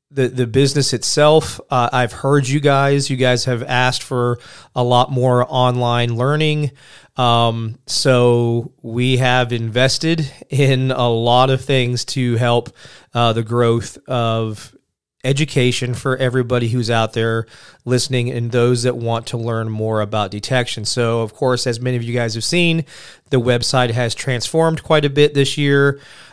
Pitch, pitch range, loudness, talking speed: 125 Hz, 120-135 Hz, -17 LUFS, 160 wpm